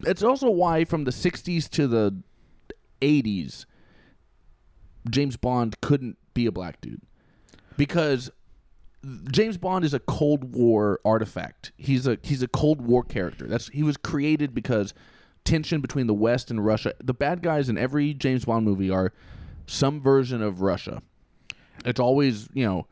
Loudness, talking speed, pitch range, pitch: -25 LUFS, 155 wpm, 110-145 Hz, 130 Hz